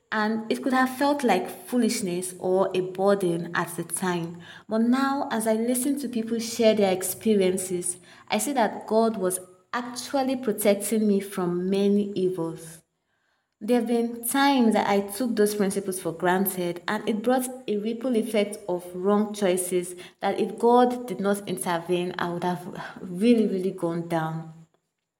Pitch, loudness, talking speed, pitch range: 200 Hz, -25 LUFS, 160 wpm, 180-225 Hz